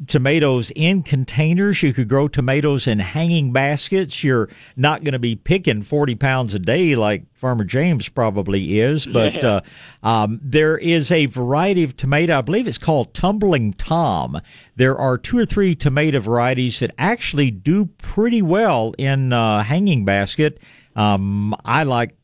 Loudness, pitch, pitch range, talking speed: -18 LUFS, 140 Hz, 120-160 Hz, 160 wpm